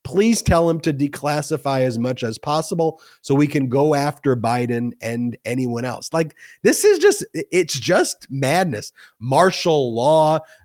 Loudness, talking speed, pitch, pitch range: -19 LUFS, 150 wpm, 145 Hz, 125-165 Hz